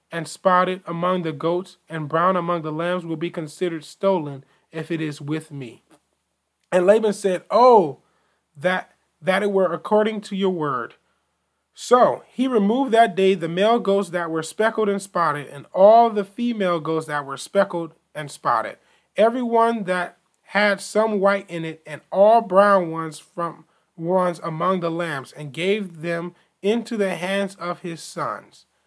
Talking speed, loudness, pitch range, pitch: 165 wpm, -21 LUFS, 160-200 Hz, 180 Hz